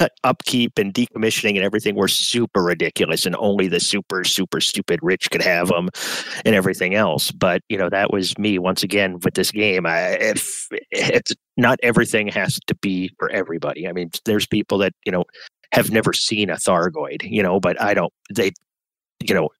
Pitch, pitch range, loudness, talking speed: 100 Hz, 95-105 Hz, -19 LUFS, 190 wpm